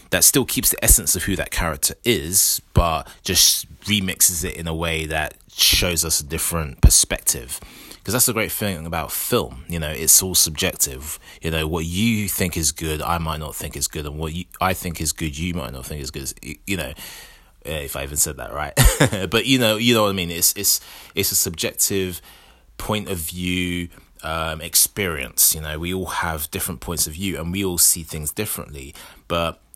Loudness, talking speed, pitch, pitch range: -19 LUFS, 210 wpm, 85 Hz, 80-95 Hz